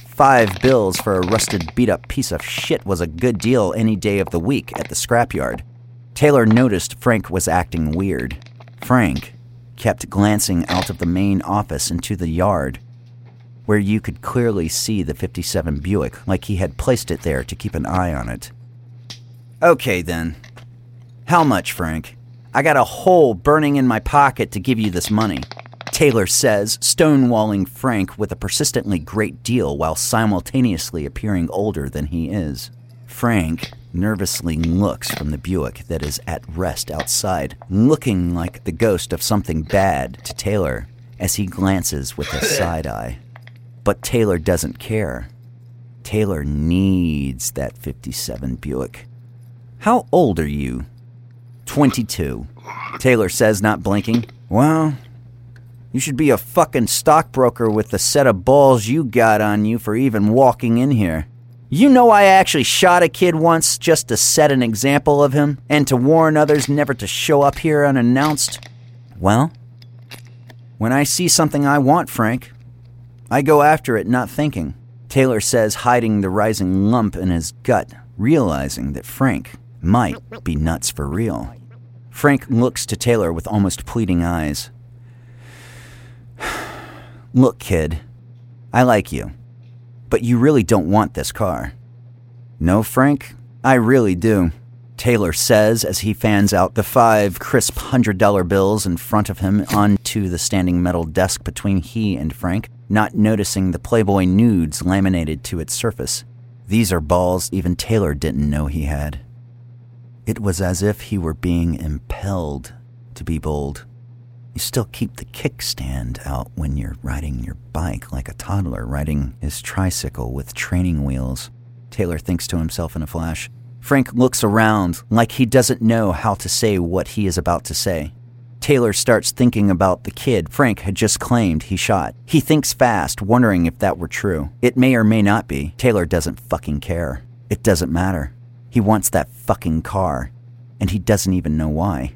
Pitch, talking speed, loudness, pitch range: 110 Hz, 160 wpm, -18 LUFS, 90-120 Hz